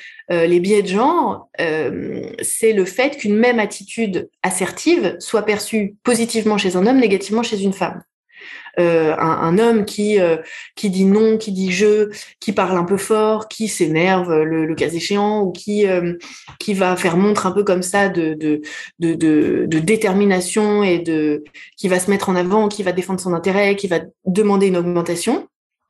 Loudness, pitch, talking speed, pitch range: -17 LUFS, 195 Hz, 185 wpm, 175-215 Hz